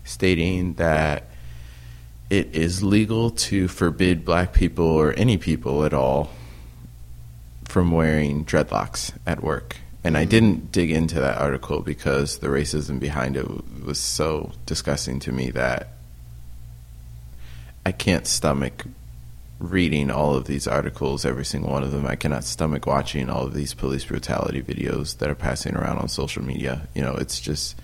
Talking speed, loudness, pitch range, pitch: 155 wpm, -23 LUFS, 60-80 Hz, 70 Hz